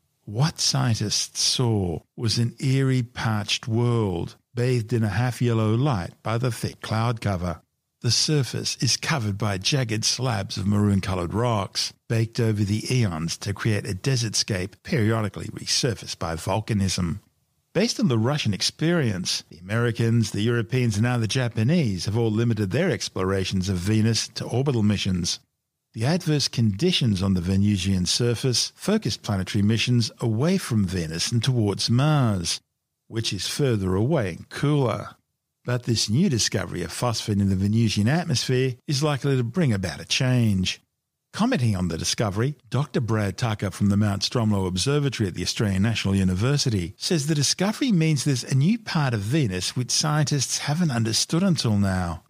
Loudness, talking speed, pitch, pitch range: -24 LUFS, 155 wpm, 115 Hz, 100-130 Hz